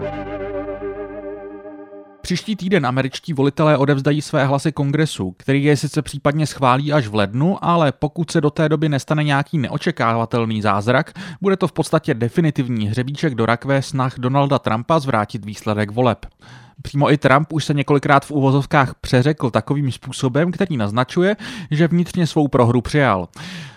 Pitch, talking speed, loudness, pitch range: 140 Hz, 145 wpm, -18 LUFS, 120-155 Hz